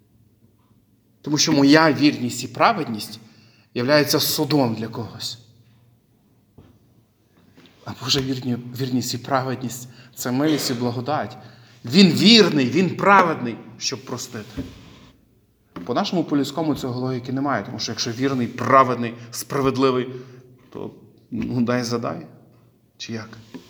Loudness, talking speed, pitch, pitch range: -20 LUFS, 110 wpm, 125 Hz, 115-135 Hz